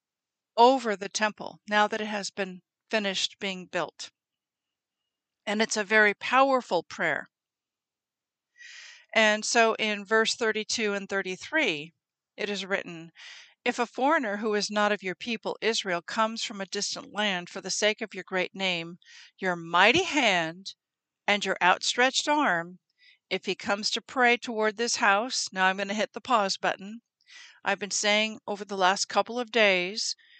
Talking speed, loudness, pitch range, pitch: 160 wpm, -26 LUFS, 195-235 Hz, 210 Hz